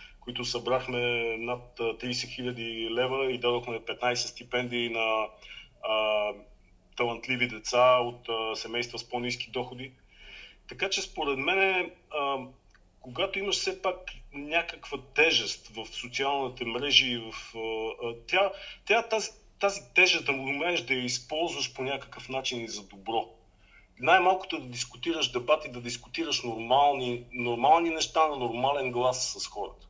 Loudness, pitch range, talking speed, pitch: -28 LUFS, 120-145 Hz, 130 wpm, 125 Hz